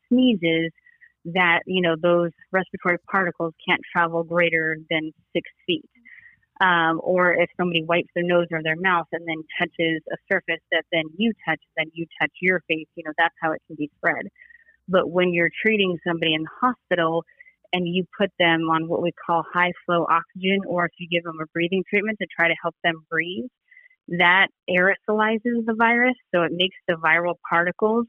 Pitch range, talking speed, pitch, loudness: 165-195 Hz, 190 wpm, 175 Hz, -22 LUFS